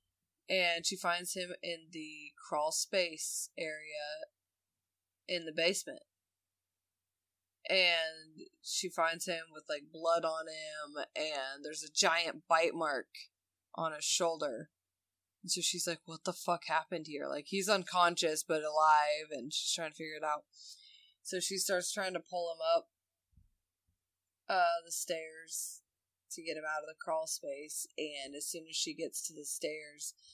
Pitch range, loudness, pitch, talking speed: 140-175 Hz, -35 LUFS, 160 Hz, 155 wpm